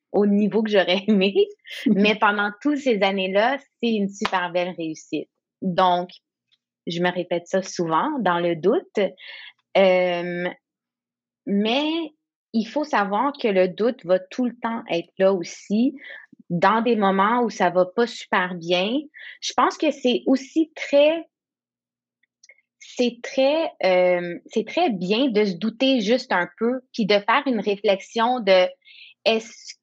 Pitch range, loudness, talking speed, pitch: 185-255 Hz, -22 LUFS, 150 wpm, 210 Hz